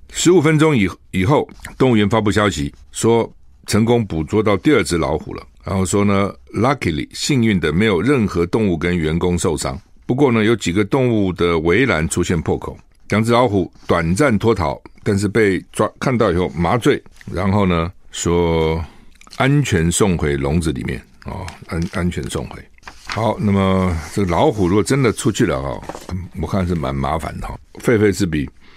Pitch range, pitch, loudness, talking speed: 85-110 Hz, 95 Hz, -17 LUFS, 265 characters per minute